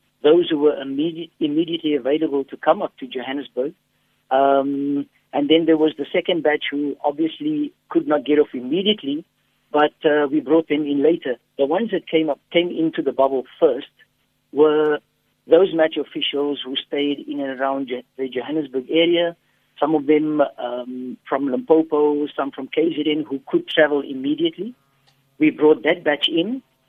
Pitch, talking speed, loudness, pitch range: 150 Hz, 165 wpm, -20 LUFS, 140-165 Hz